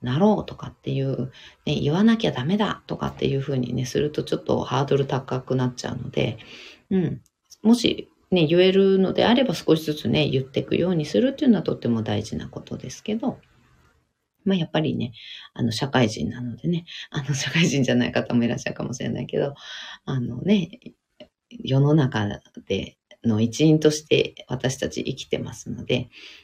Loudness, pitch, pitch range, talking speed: -23 LUFS, 140 Hz, 125-175 Hz, 365 characters per minute